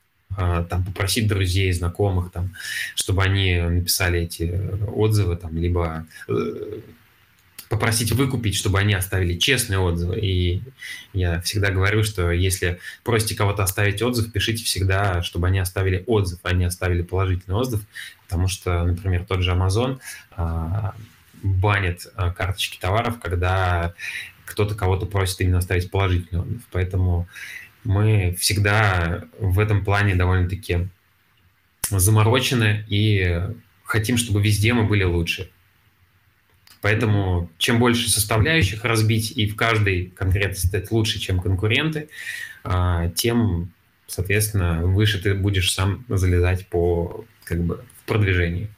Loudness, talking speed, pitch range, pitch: -22 LUFS, 120 wpm, 90-105 Hz, 95 Hz